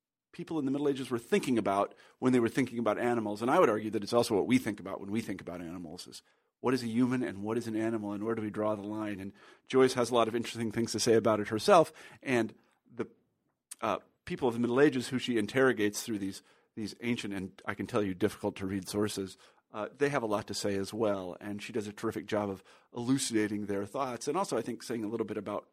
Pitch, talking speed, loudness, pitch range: 110 Hz, 260 wpm, -32 LUFS, 105-120 Hz